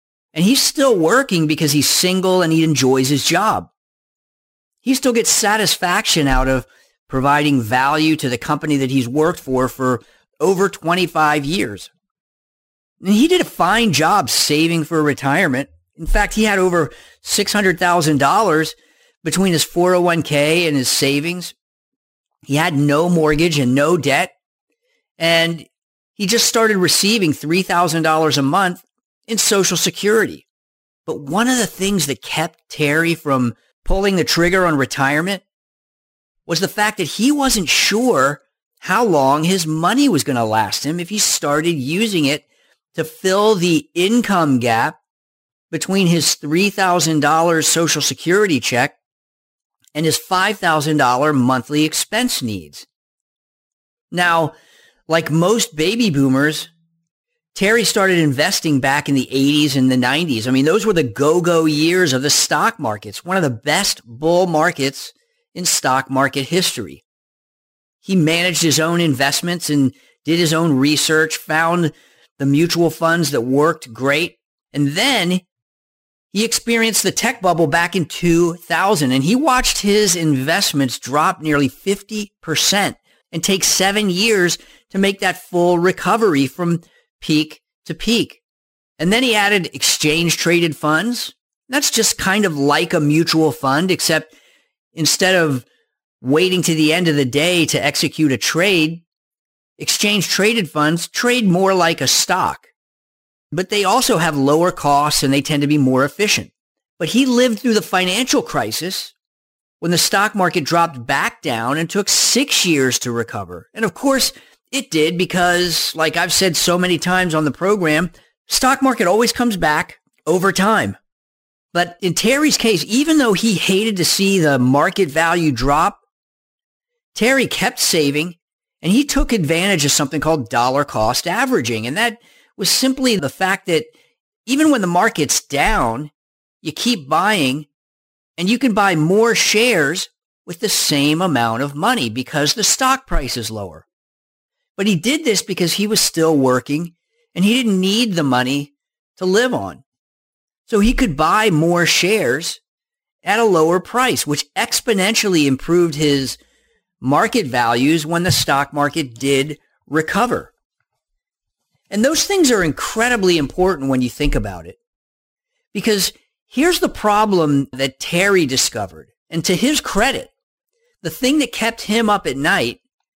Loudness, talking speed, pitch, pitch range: -16 LUFS, 150 wpm, 170 Hz, 145-205 Hz